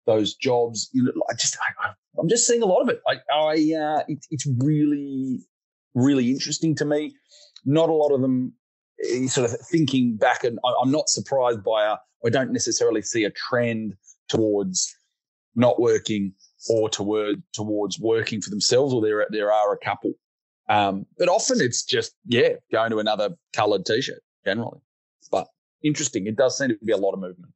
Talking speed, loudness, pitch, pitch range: 185 wpm, -23 LUFS, 130 Hz, 110-155 Hz